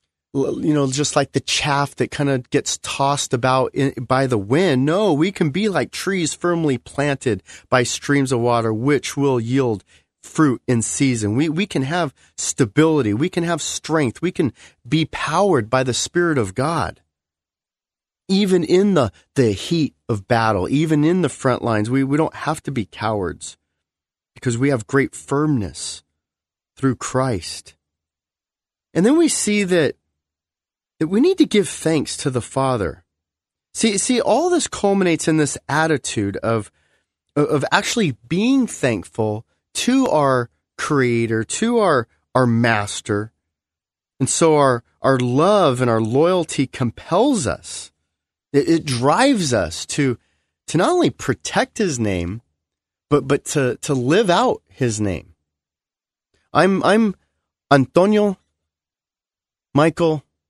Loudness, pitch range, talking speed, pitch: -19 LUFS, 100-160 Hz, 145 wpm, 130 Hz